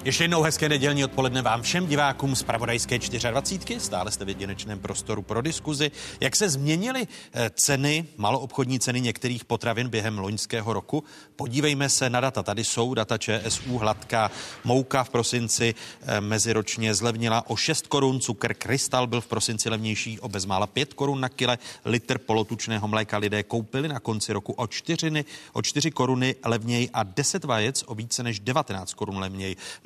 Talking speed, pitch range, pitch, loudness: 165 wpm, 110-135 Hz, 120 Hz, -26 LUFS